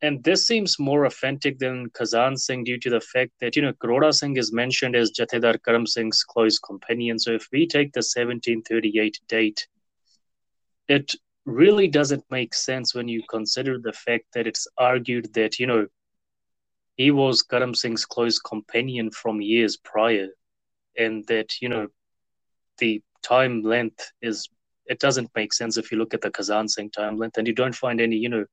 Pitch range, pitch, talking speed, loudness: 110-130 Hz, 115 Hz, 180 wpm, -23 LUFS